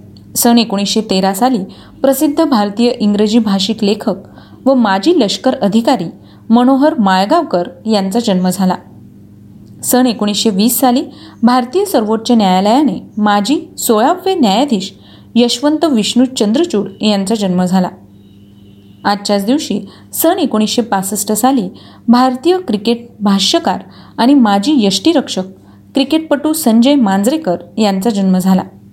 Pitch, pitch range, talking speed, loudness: 225 Hz, 195-265 Hz, 110 wpm, -12 LUFS